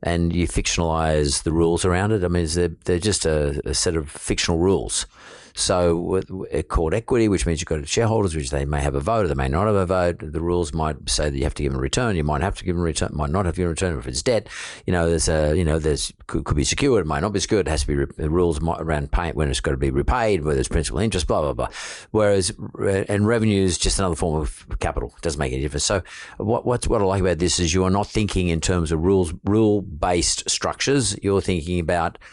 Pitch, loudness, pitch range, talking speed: 85 Hz, -22 LUFS, 75-95 Hz, 270 wpm